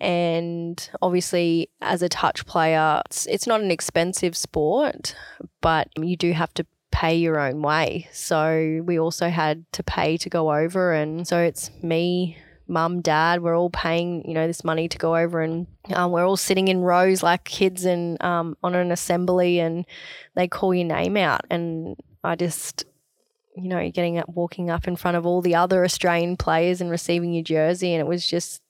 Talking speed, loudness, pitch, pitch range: 190 wpm, -23 LUFS, 170 Hz, 165-180 Hz